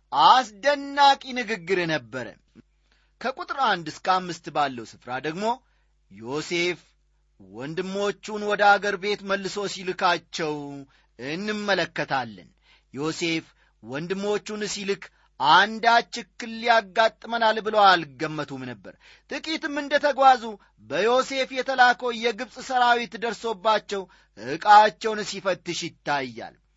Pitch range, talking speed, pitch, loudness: 160-235 Hz, 85 wpm, 200 Hz, -23 LUFS